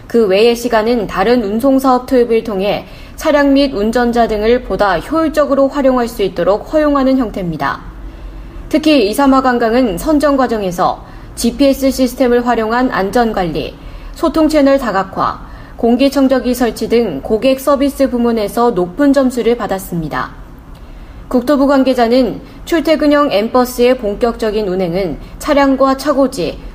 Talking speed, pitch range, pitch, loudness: 310 characters per minute, 220-275 Hz, 245 Hz, -13 LUFS